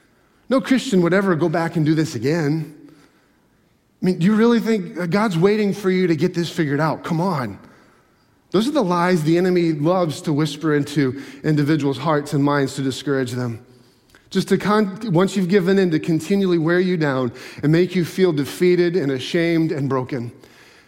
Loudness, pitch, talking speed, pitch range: -19 LUFS, 170 Hz, 185 wpm, 145-185 Hz